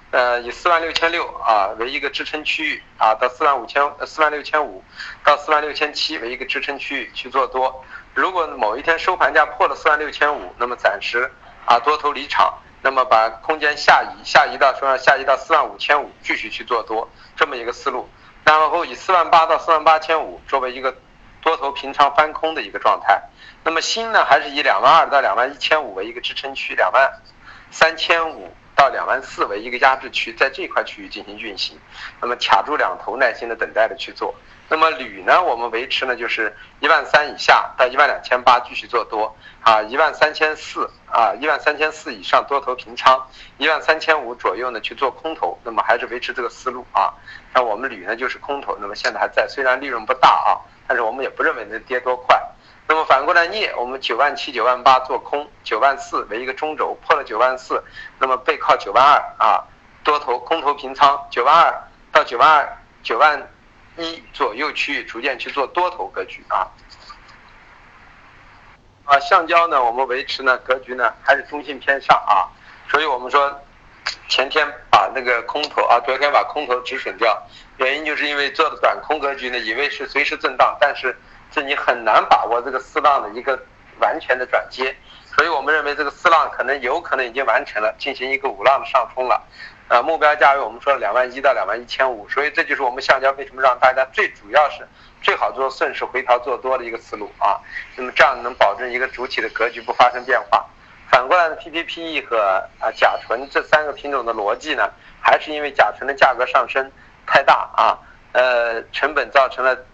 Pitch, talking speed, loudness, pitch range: 140 Hz, 310 characters per minute, -18 LUFS, 130-155 Hz